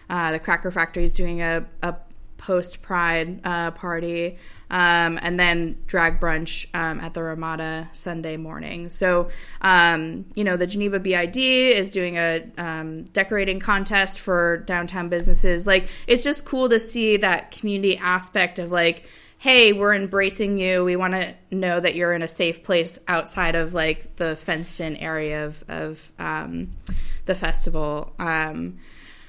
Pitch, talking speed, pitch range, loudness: 175 Hz, 160 wpm, 165-190 Hz, -22 LUFS